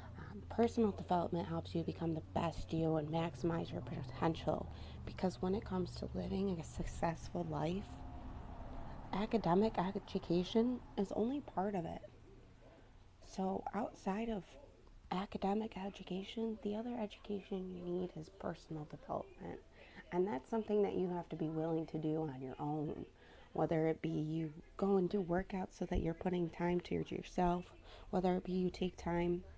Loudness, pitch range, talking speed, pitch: -40 LUFS, 160-195 Hz, 155 wpm, 180 Hz